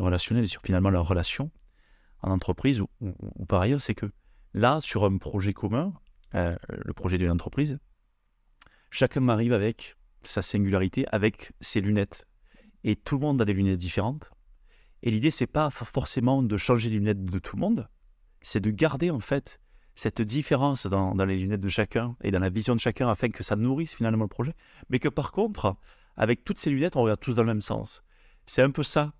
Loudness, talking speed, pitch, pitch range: -27 LUFS, 205 wpm, 115 Hz, 100-135 Hz